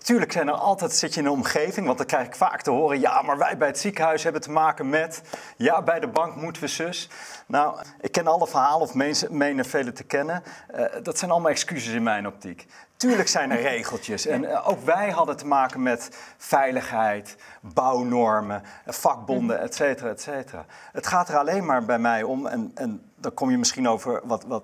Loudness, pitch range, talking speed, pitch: -24 LUFS, 130-185 Hz, 210 wpm, 155 Hz